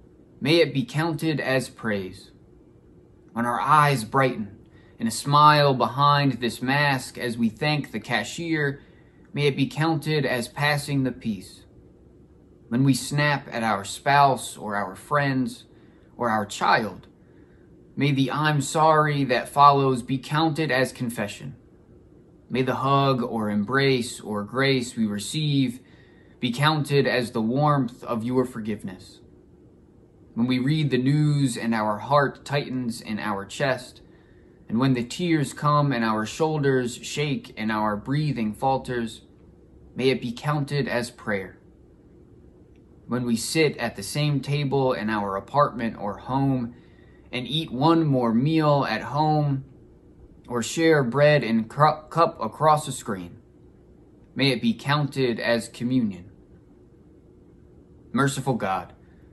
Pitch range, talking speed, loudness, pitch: 110-145 Hz, 135 wpm, -24 LUFS, 130 Hz